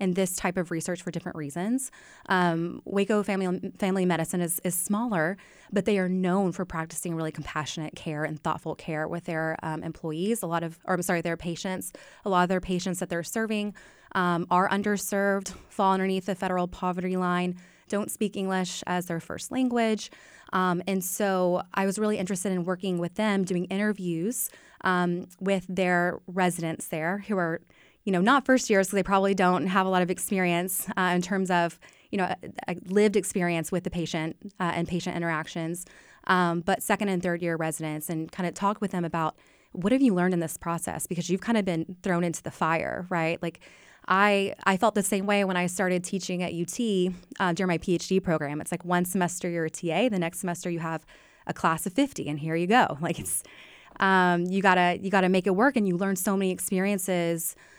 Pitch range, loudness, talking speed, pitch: 170-195 Hz, -27 LUFS, 205 wpm, 180 Hz